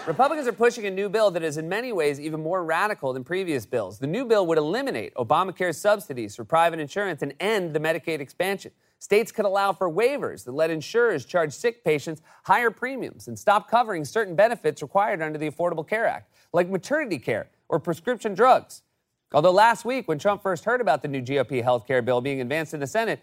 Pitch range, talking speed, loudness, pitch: 155-220 Hz, 210 wpm, -24 LUFS, 180 Hz